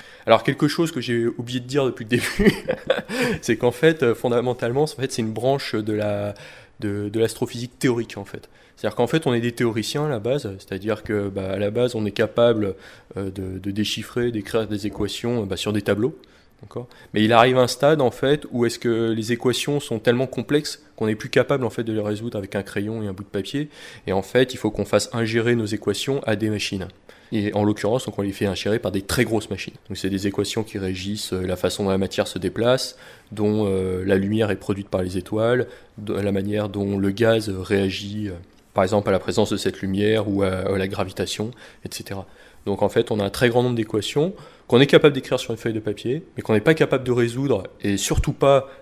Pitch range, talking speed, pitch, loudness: 100-120 Hz, 225 wpm, 110 Hz, -22 LUFS